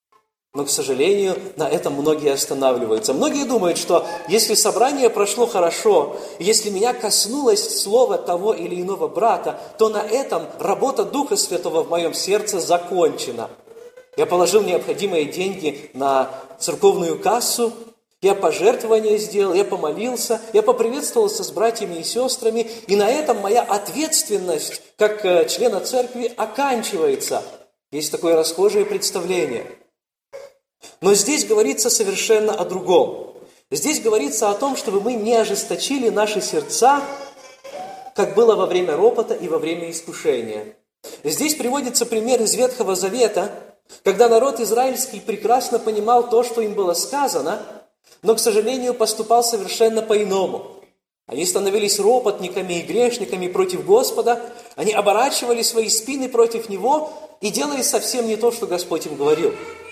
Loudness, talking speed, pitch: -19 LUFS, 130 wpm, 235 Hz